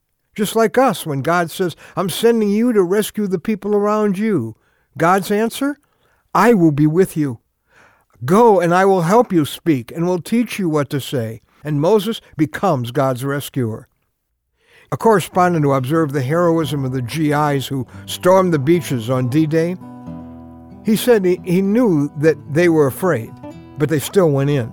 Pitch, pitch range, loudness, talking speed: 160 Hz, 135-195 Hz, -17 LUFS, 165 wpm